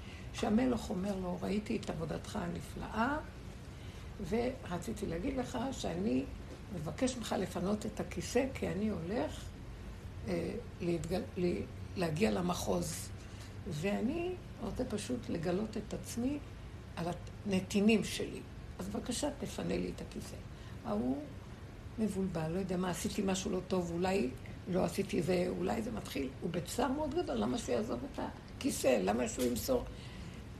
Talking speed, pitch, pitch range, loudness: 125 wpm, 190 Hz, 175-220 Hz, -37 LUFS